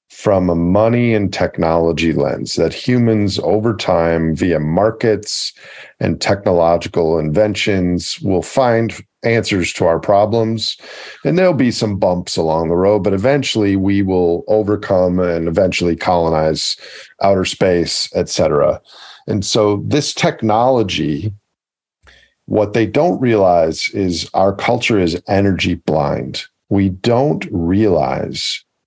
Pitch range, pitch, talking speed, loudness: 85-110 Hz, 100 Hz, 120 wpm, -15 LUFS